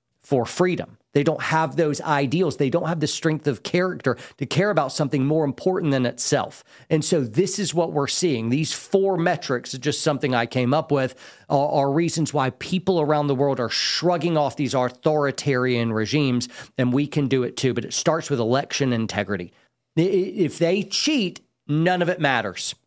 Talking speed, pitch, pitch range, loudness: 185 wpm, 150 Hz, 130-170 Hz, -22 LUFS